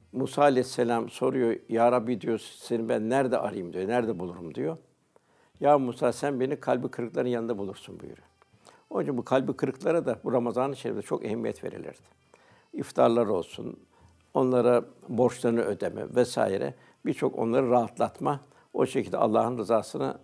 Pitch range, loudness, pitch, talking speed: 115-130 Hz, -28 LUFS, 125 Hz, 140 wpm